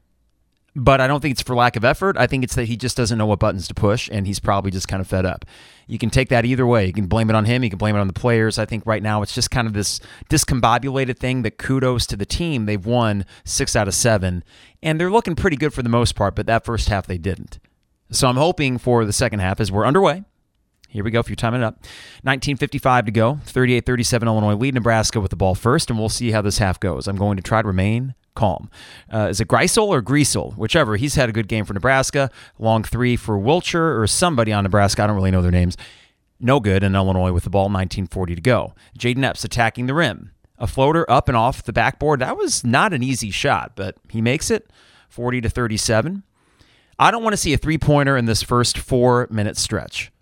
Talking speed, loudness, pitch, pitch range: 245 wpm, -19 LUFS, 115 Hz, 100-130 Hz